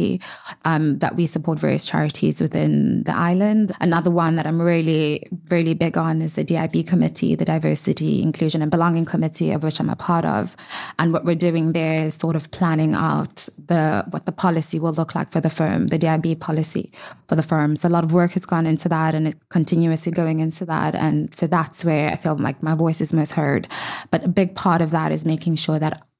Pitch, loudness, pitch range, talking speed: 165 Hz, -20 LUFS, 155-170 Hz, 220 wpm